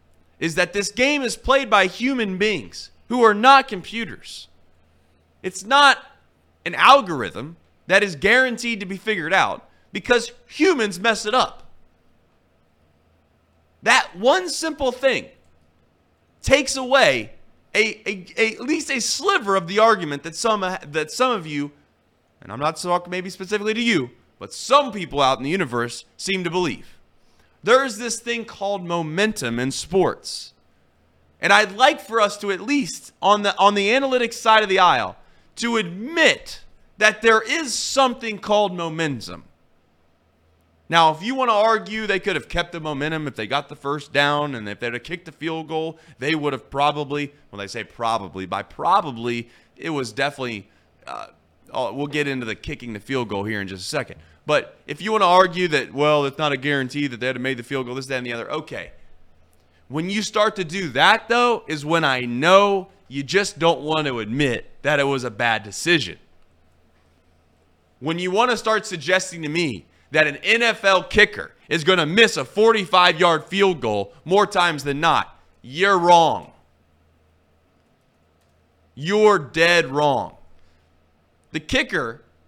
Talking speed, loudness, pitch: 170 wpm, -20 LUFS, 160 Hz